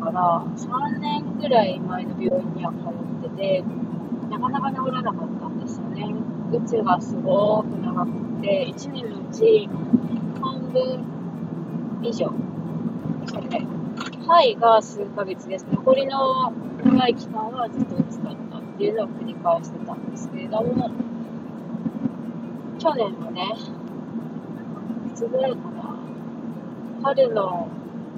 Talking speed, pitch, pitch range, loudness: 220 characters per minute, 230 Hz, 215-240 Hz, -24 LUFS